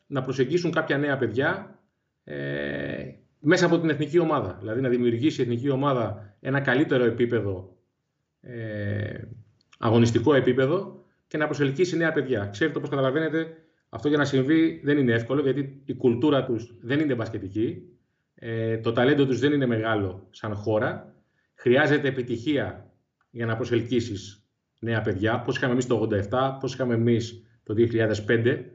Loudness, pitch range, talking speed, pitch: -25 LUFS, 115-145 Hz, 150 wpm, 125 Hz